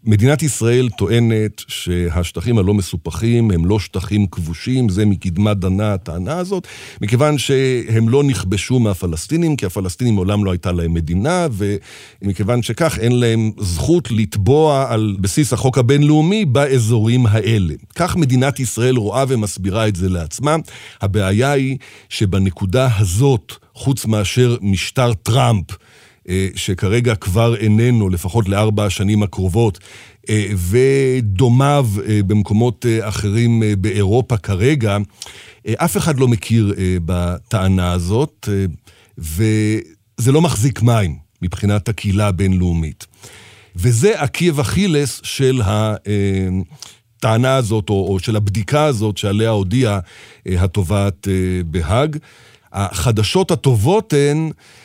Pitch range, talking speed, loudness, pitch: 100-125 Hz, 105 wpm, -16 LUFS, 110 Hz